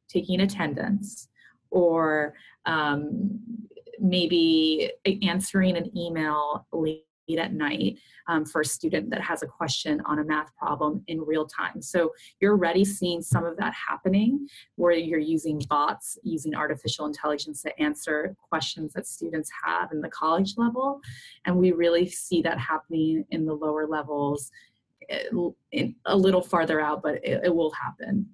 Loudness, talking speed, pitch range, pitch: -26 LUFS, 150 wpm, 155-185 Hz, 165 Hz